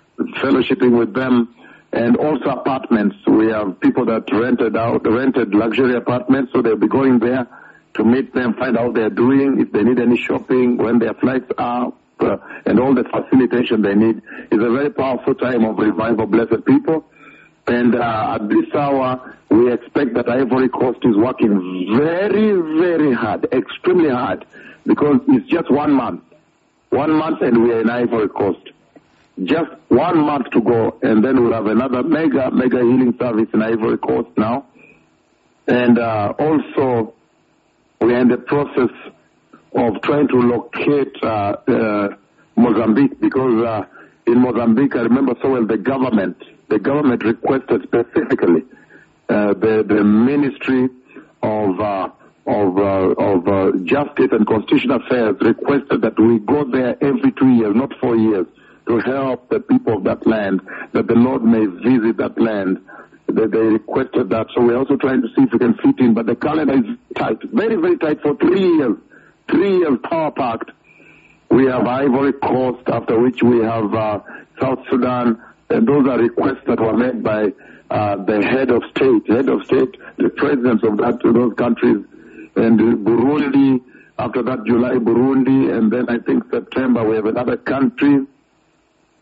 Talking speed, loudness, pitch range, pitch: 165 wpm, -16 LUFS, 115-135 Hz, 125 Hz